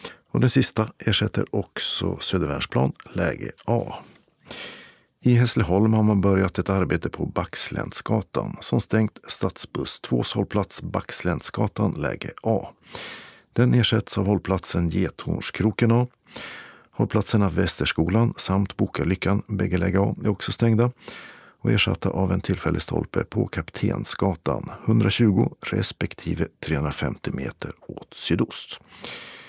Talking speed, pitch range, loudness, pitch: 110 wpm, 95-115 Hz, -24 LUFS, 100 Hz